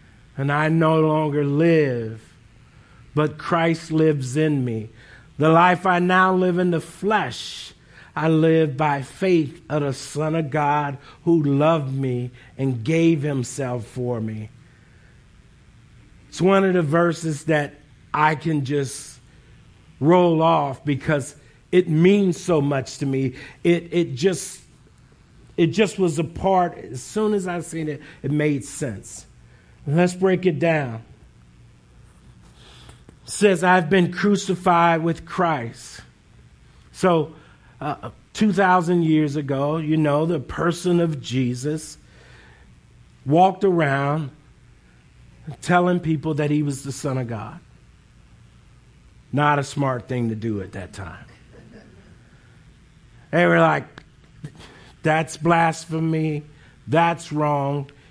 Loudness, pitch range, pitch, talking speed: -21 LUFS, 130-165 Hz, 150 Hz, 125 wpm